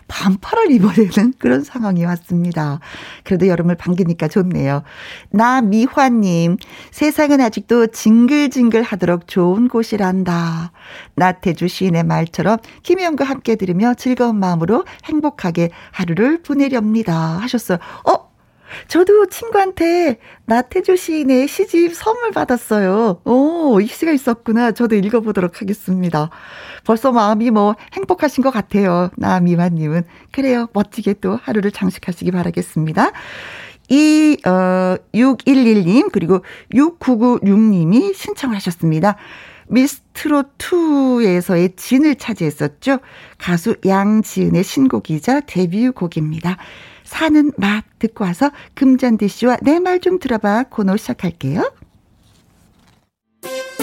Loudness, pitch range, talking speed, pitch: -16 LUFS, 180-265 Hz, 270 characters per minute, 220 Hz